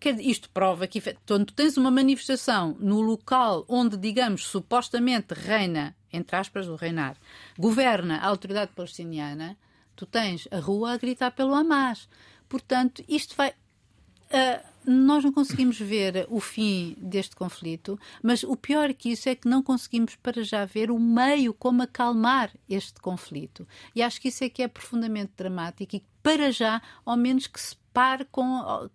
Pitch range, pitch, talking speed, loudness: 195-255 Hz, 235 Hz, 160 wpm, -26 LUFS